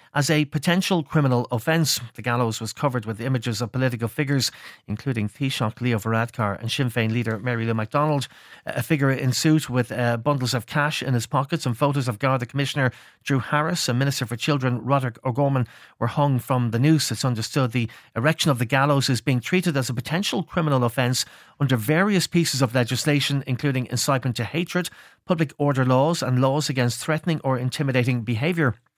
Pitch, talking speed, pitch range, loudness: 130 Hz, 185 wpm, 120-145 Hz, -23 LUFS